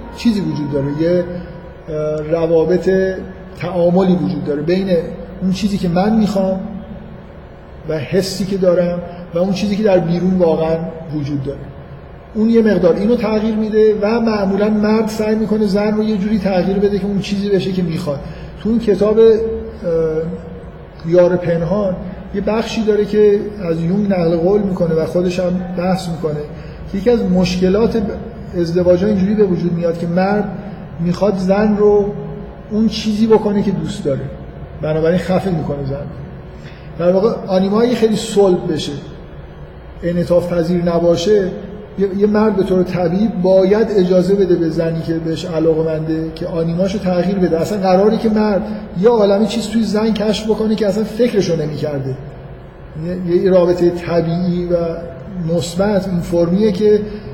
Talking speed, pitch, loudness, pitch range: 150 wpm, 185 Hz, -16 LUFS, 170-205 Hz